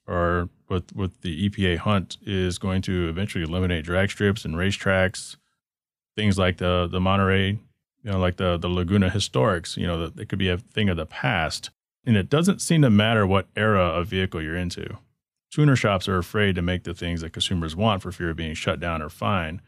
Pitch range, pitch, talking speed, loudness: 90-105 Hz, 95 Hz, 210 wpm, -24 LUFS